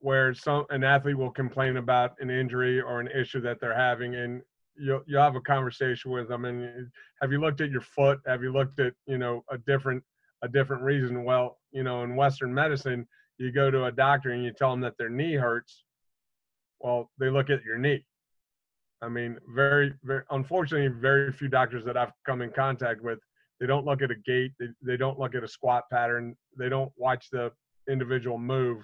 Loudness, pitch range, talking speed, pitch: -28 LUFS, 125-135 Hz, 210 wpm, 130 Hz